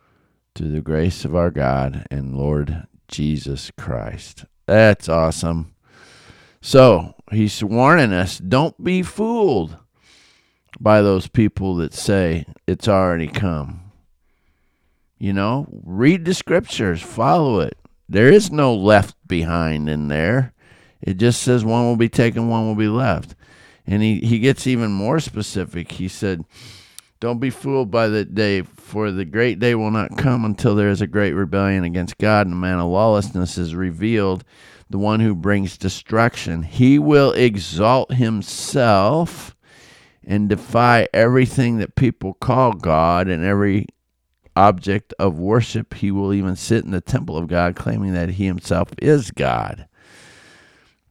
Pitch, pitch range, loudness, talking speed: 100 Hz, 90-120 Hz, -18 LUFS, 145 wpm